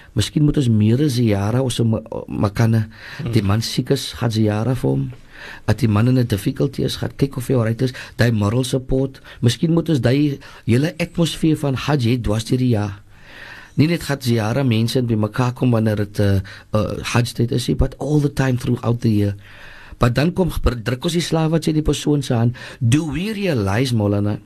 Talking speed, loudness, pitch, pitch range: 180 wpm, -19 LUFS, 120 Hz, 110-140 Hz